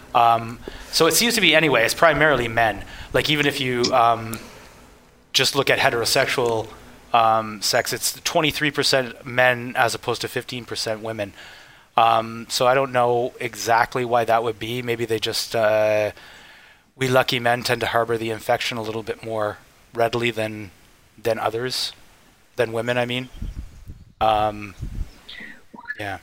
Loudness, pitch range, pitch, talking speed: -20 LUFS, 110-125 Hz, 115 Hz, 150 wpm